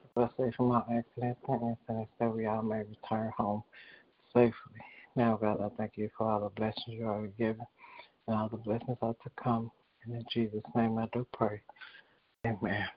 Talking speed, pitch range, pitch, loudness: 190 wpm, 110-120 Hz, 115 Hz, -34 LUFS